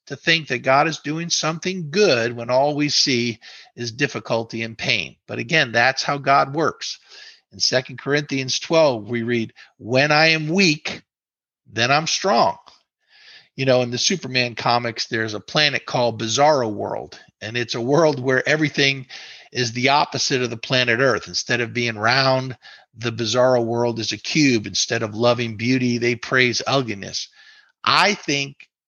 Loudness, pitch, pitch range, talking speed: -19 LUFS, 130 Hz, 120-150 Hz, 165 wpm